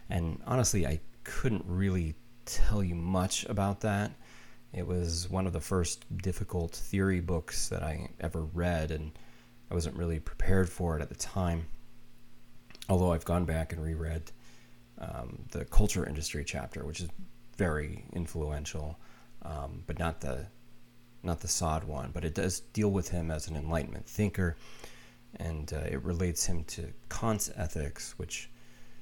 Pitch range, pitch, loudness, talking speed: 80-105 Hz, 90 Hz, -34 LUFS, 155 wpm